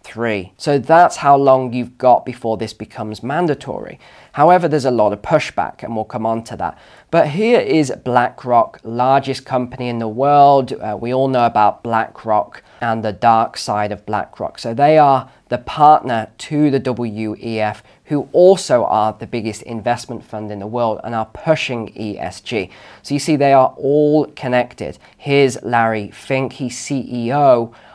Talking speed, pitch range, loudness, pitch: 165 wpm, 110-135 Hz, -16 LUFS, 120 Hz